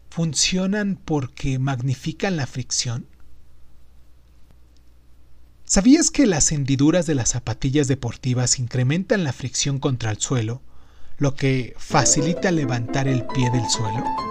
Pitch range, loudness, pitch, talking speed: 110-155 Hz, -21 LUFS, 130 Hz, 115 wpm